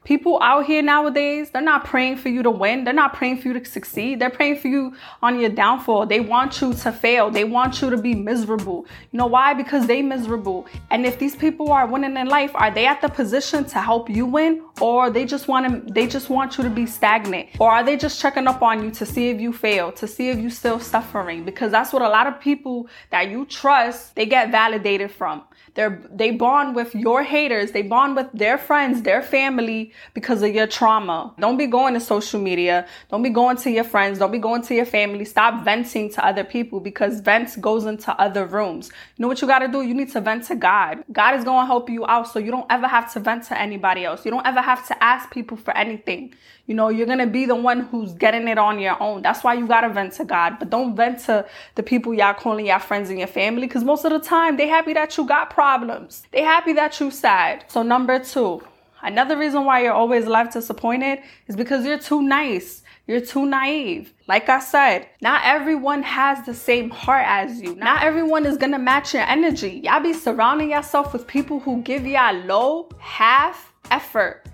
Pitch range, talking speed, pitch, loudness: 220-275 Hz, 230 wpm, 245 Hz, -19 LUFS